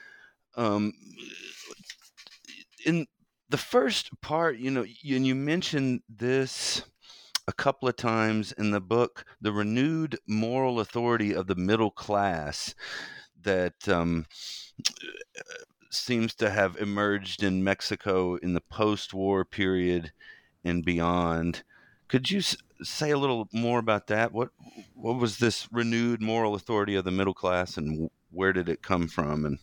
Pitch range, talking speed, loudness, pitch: 95-125 Hz, 135 wpm, -28 LUFS, 110 Hz